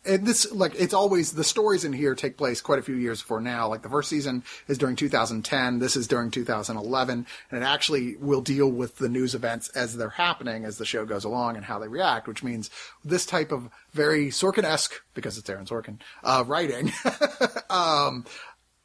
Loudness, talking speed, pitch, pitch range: -26 LUFS, 215 wpm, 130 Hz, 115-150 Hz